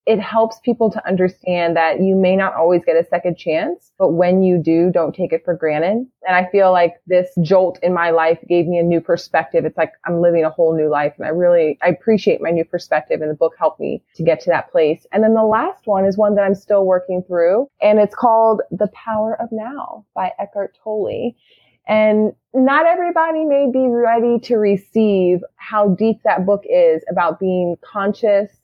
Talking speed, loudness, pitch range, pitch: 210 wpm, -16 LUFS, 170-220 Hz, 190 Hz